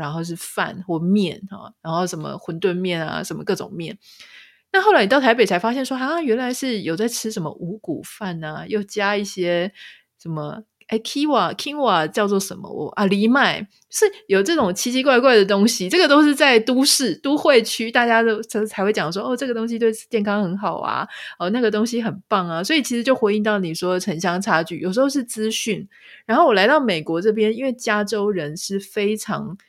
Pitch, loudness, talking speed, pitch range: 215 Hz, -20 LUFS, 305 characters per minute, 185-245 Hz